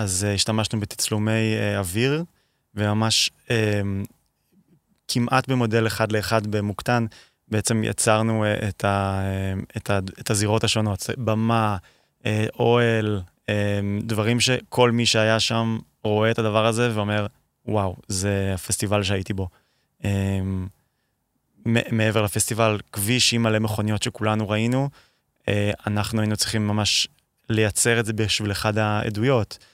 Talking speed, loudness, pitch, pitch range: 125 wpm, -23 LUFS, 110 Hz, 105-115 Hz